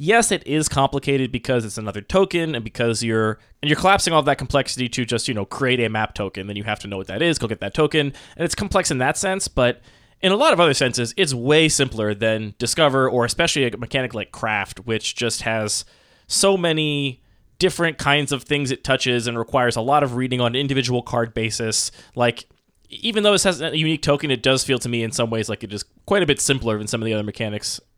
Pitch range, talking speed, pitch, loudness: 110-150 Hz, 240 wpm, 125 Hz, -20 LUFS